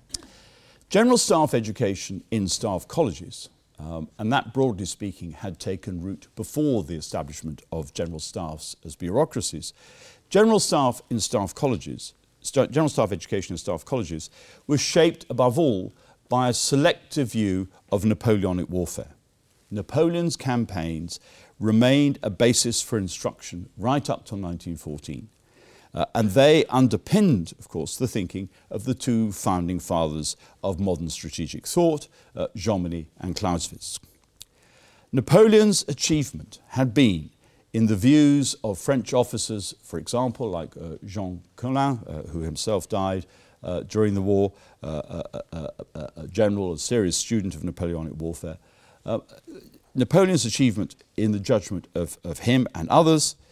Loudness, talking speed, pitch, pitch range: -24 LUFS, 140 wpm, 110 Hz, 90-130 Hz